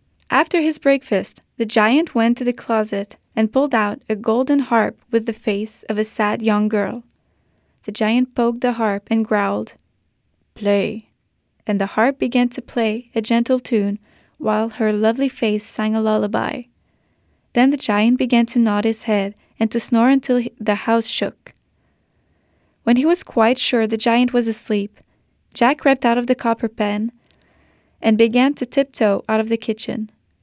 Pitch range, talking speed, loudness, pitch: 215-245 Hz, 170 wpm, -19 LUFS, 225 Hz